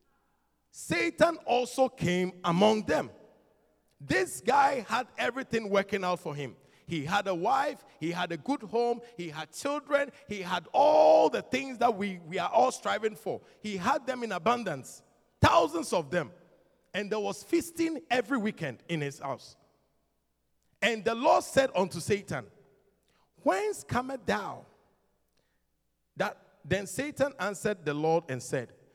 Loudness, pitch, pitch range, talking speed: -29 LUFS, 205 Hz, 175-260 Hz, 145 wpm